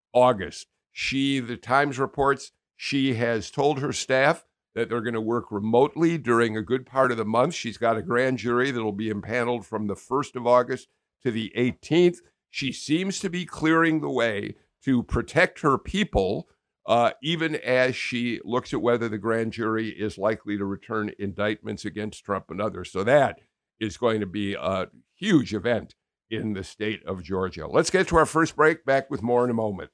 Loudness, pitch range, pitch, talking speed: -25 LUFS, 110-135 Hz, 120 Hz, 190 wpm